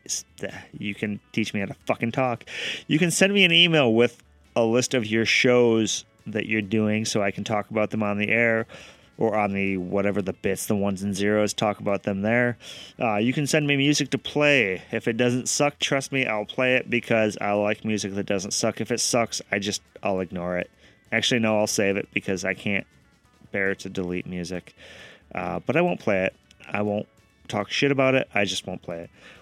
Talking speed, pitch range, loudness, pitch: 220 wpm, 100-120 Hz, -24 LUFS, 105 Hz